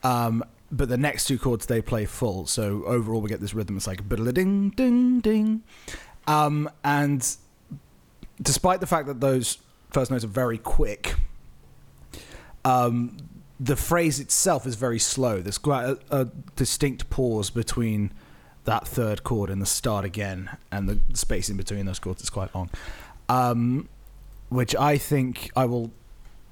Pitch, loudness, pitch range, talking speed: 125 Hz, -25 LUFS, 105-140 Hz, 155 wpm